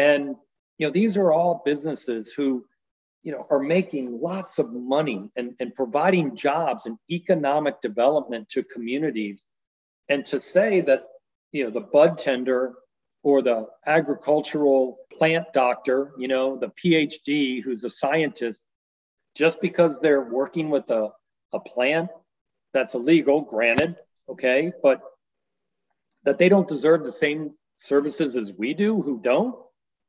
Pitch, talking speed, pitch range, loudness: 145 Hz, 140 wpm, 130-165 Hz, -23 LUFS